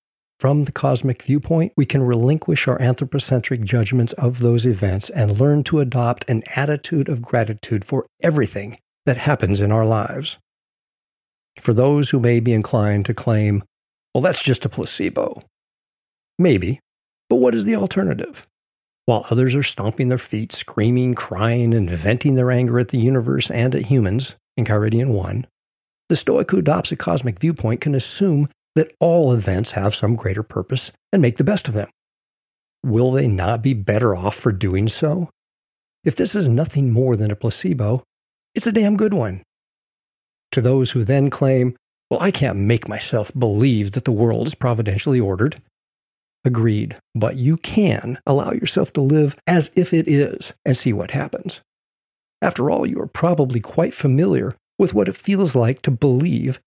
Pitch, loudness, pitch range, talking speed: 125 Hz, -19 LUFS, 115-145 Hz, 170 wpm